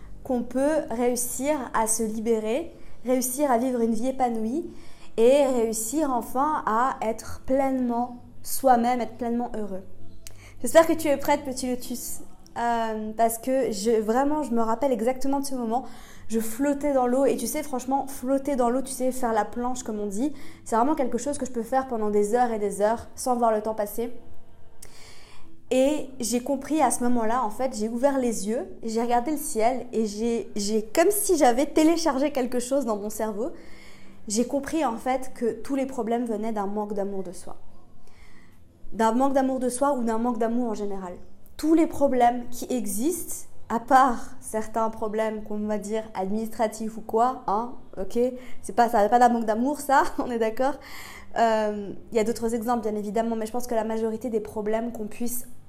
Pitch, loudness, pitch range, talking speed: 240 Hz, -25 LUFS, 220-265 Hz, 195 wpm